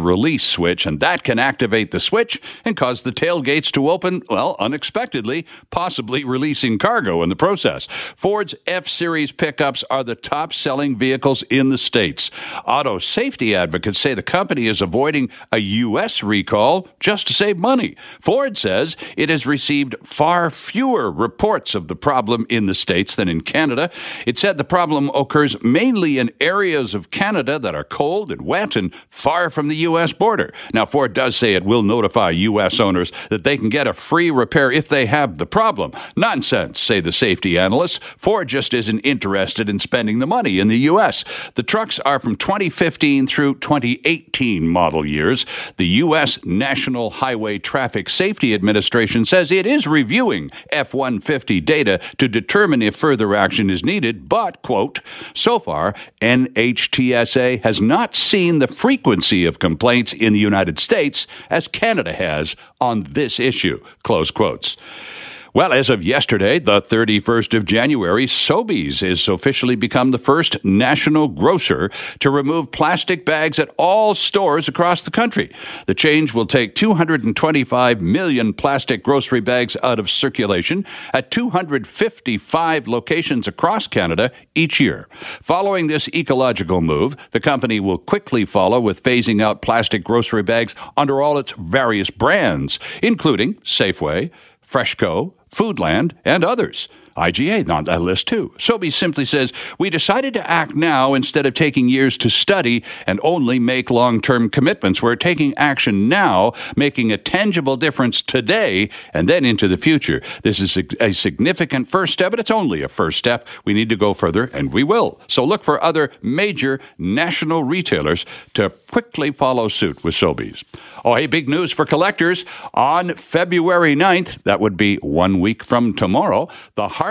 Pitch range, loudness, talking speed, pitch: 115-165 Hz, -17 LUFS, 160 wpm, 135 Hz